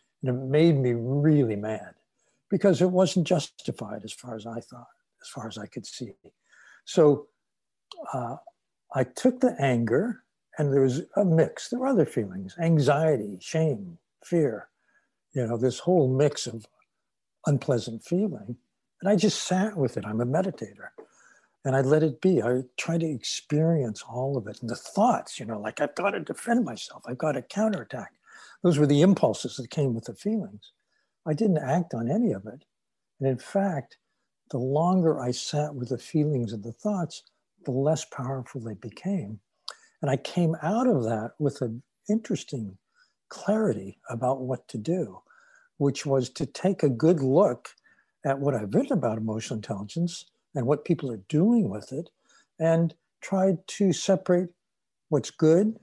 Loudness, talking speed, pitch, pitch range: -26 LUFS, 170 wpm, 150 Hz, 125-180 Hz